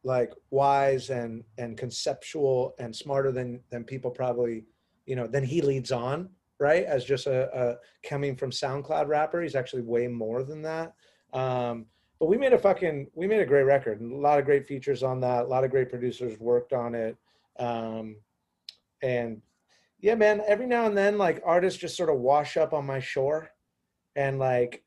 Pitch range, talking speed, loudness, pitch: 120-145 Hz, 190 wpm, -27 LUFS, 130 Hz